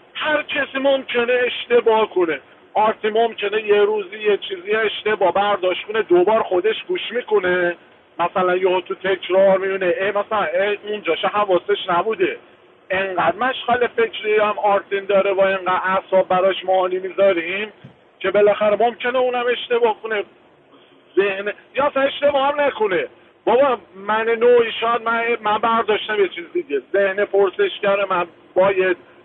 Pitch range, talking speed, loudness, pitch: 195-275 Hz, 135 wpm, -19 LUFS, 215 Hz